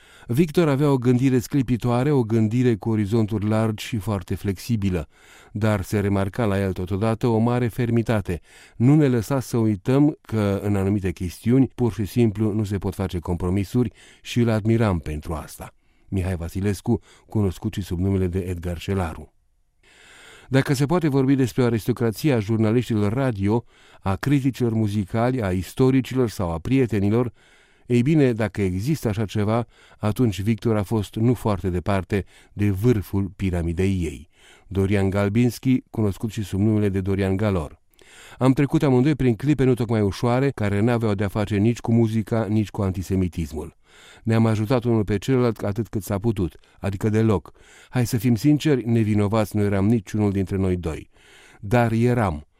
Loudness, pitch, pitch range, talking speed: -22 LUFS, 110 Hz, 100-120 Hz, 155 wpm